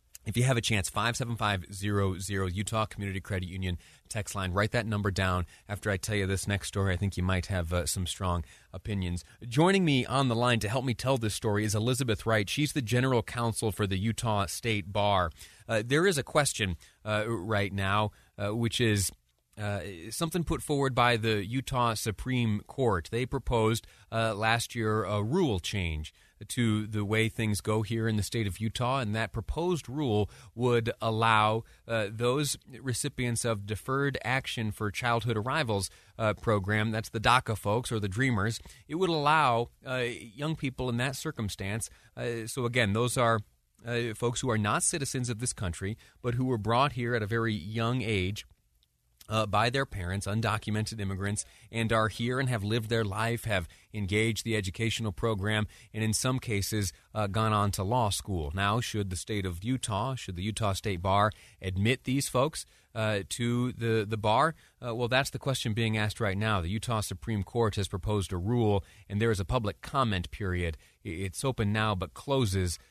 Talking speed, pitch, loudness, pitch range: 190 wpm, 110 Hz, -30 LUFS, 100-120 Hz